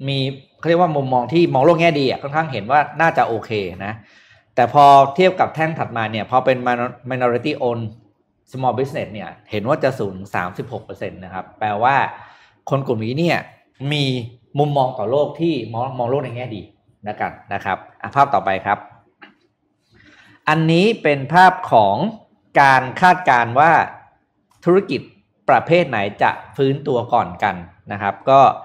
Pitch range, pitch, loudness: 115-155 Hz, 135 Hz, -17 LUFS